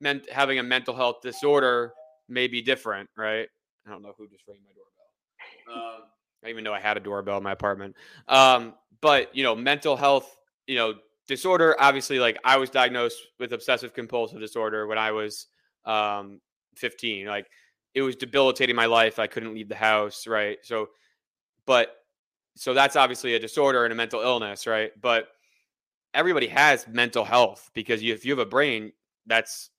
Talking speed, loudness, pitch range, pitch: 180 wpm, -24 LUFS, 110-130 Hz, 115 Hz